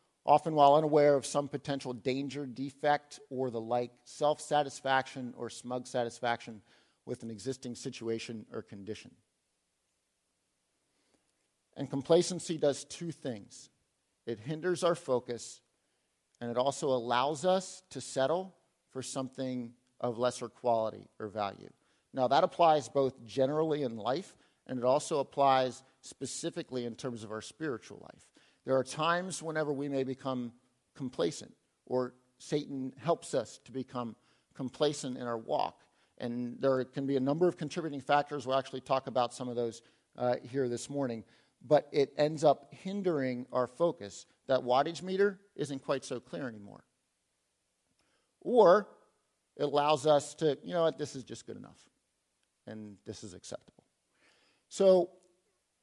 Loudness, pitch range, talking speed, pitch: -32 LUFS, 120-150 Hz, 145 wpm, 130 Hz